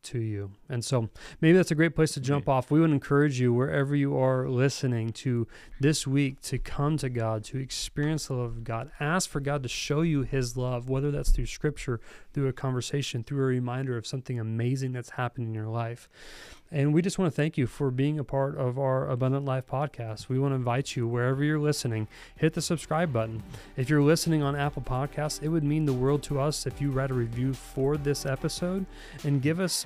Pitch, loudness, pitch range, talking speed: 135 Hz, -28 LUFS, 125-145 Hz, 225 wpm